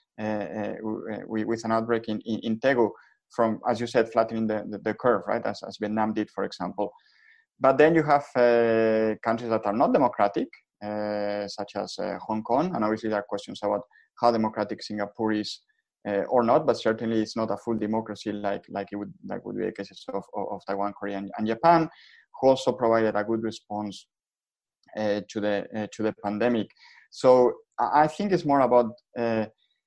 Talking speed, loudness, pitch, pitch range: 200 wpm, -26 LUFS, 110 Hz, 105-120 Hz